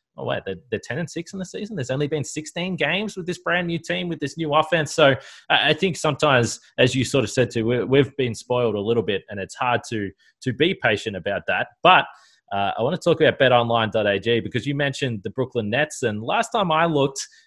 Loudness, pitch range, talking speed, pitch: -22 LUFS, 115-165 Hz, 230 wpm, 135 Hz